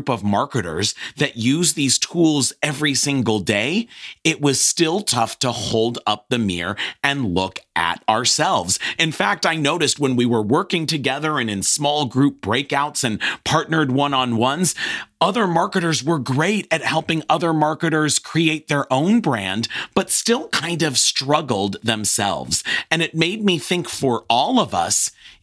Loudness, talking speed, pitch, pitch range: -19 LUFS, 160 wpm, 145 Hz, 120-160 Hz